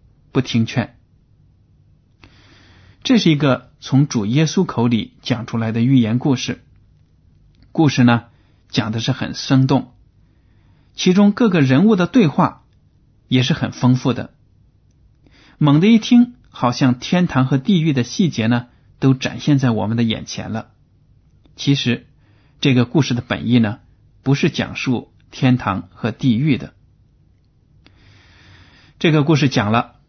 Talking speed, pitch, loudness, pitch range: 190 characters per minute, 125 Hz, -17 LUFS, 110-140 Hz